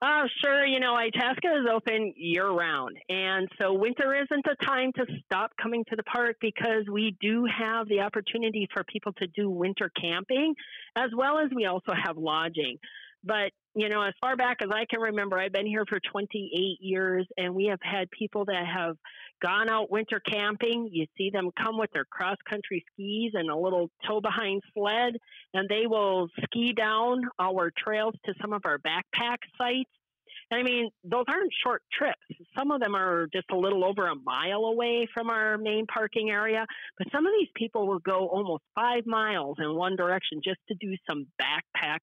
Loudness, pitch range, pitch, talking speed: -28 LUFS, 190-235 Hz, 215 Hz, 195 wpm